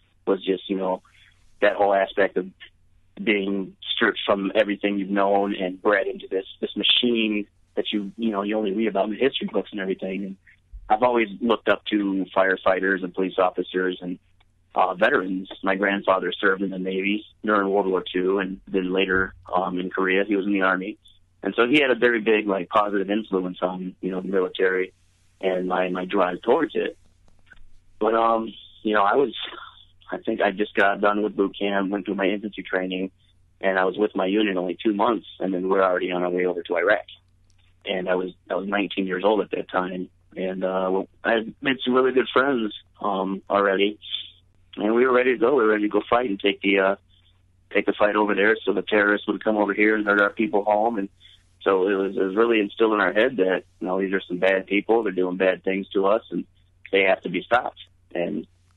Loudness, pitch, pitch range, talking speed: -23 LUFS, 95 Hz, 90-105 Hz, 220 wpm